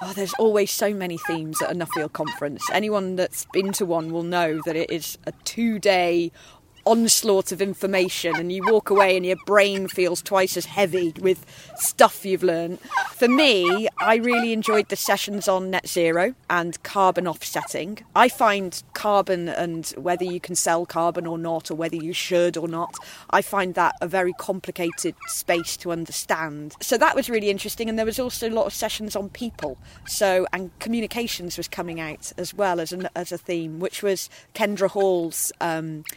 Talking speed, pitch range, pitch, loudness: 185 wpm, 170-205 Hz, 185 Hz, -23 LUFS